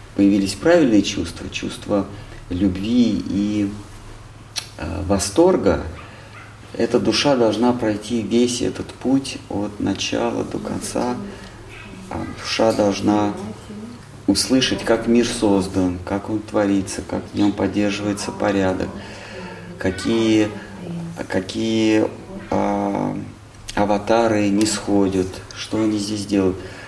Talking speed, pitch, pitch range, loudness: 100 wpm, 105 Hz, 100-115 Hz, -20 LUFS